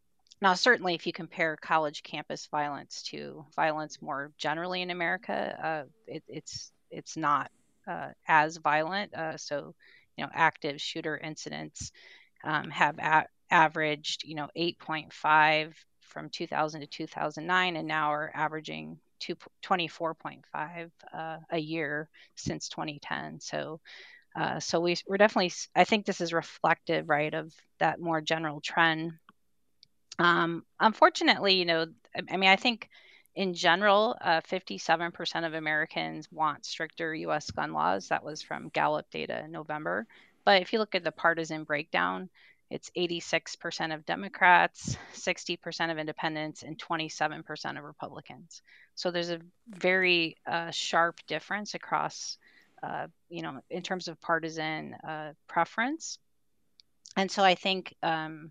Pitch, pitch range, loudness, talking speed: 165 Hz, 155-175 Hz, -29 LUFS, 140 wpm